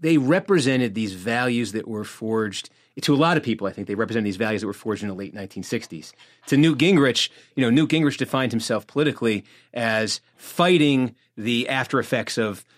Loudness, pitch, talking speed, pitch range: -22 LUFS, 115 Hz, 195 wpm, 110-140 Hz